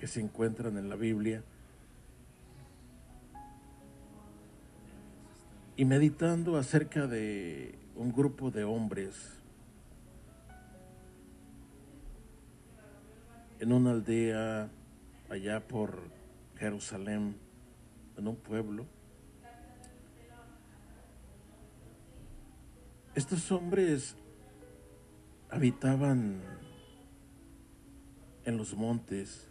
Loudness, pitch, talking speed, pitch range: -34 LUFS, 110 Hz, 60 wpm, 75-125 Hz